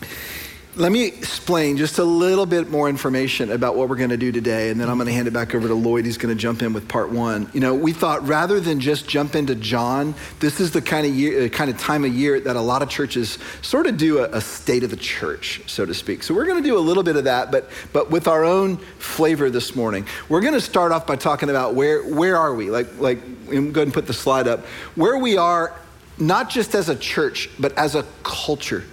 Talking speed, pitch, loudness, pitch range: 245 wpm, 145 Hz, -20 LUFS, 120-165 Hz